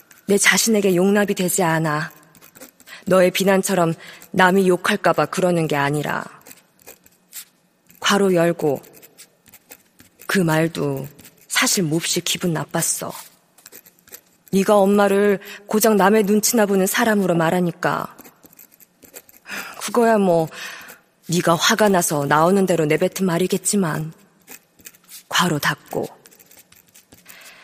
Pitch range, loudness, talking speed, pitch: 165-200 Hz, -18 LUFS, 210 characters per minute, 185 Hz